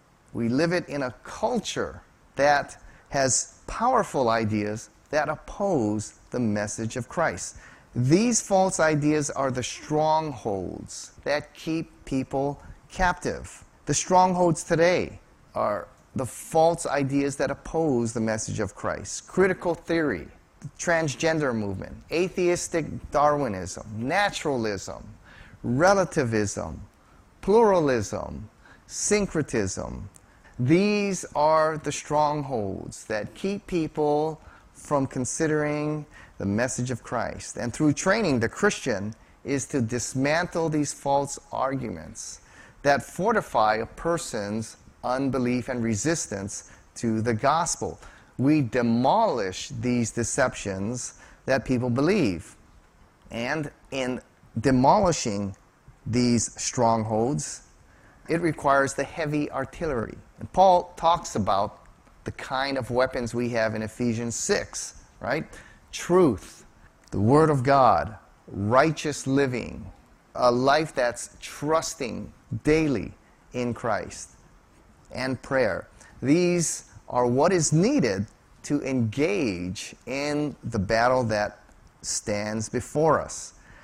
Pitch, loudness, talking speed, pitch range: 130 Hz, -25 LUFS, 105 wpm, 110-155 Hz